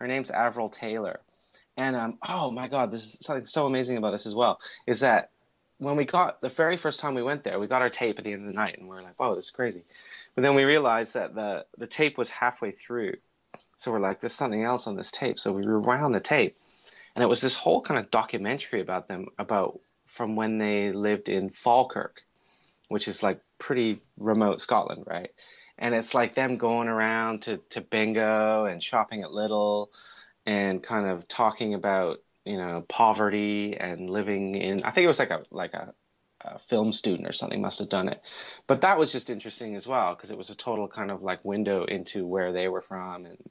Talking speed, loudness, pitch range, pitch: 225 wpm, -27 LUFS, 105-125 Hz, 110 Hz